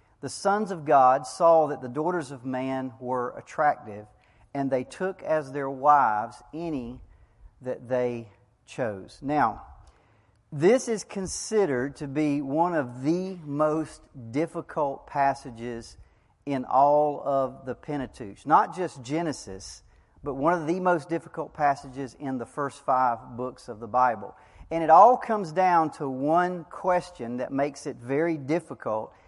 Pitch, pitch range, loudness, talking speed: 140 Hz, 125-160 Hz, -26 LUFS, 145 wpm